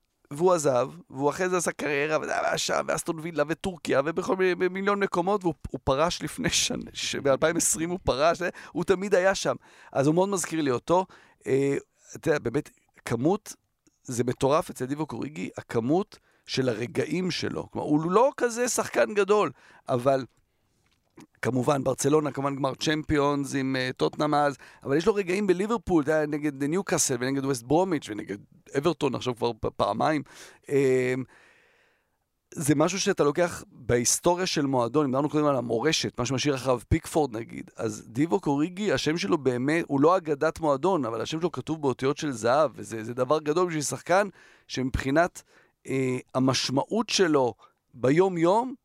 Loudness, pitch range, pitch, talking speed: -26 LUFS, 135-175 Hz, 150 Hz, 155 wpm